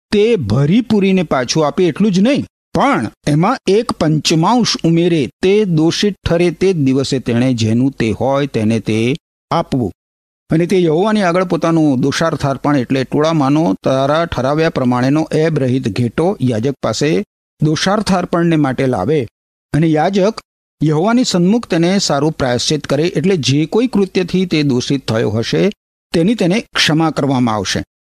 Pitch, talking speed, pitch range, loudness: 155 Hz, 145 wpm, 135-185 Hz, -14 LUFS